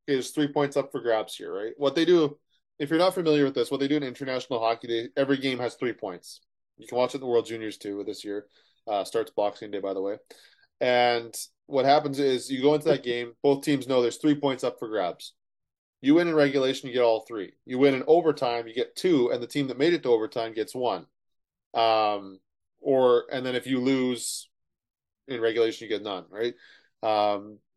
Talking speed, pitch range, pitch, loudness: 225 wpm, 115-145 Hz, 130 Hz, -26 LUFS